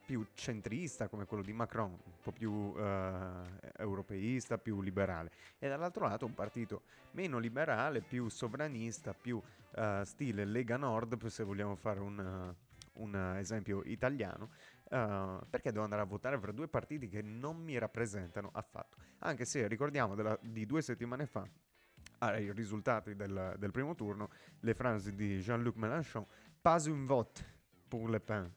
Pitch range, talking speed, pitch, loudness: 100-120 Hz, 155 wpm, 110 Hz, -40 LUFS